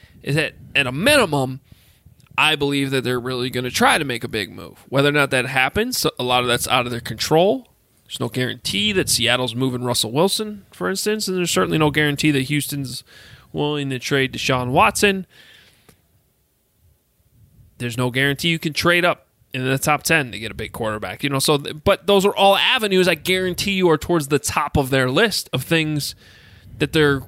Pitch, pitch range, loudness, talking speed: 140 Hz, 125-170 Hz, -19 LUFS, 200 wpm